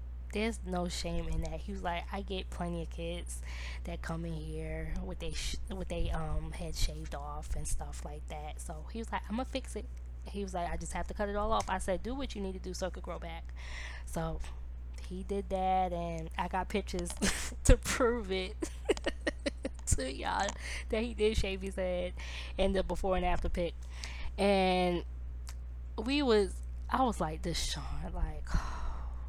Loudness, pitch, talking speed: -36 LUFS, 170 Hz, 200 wpm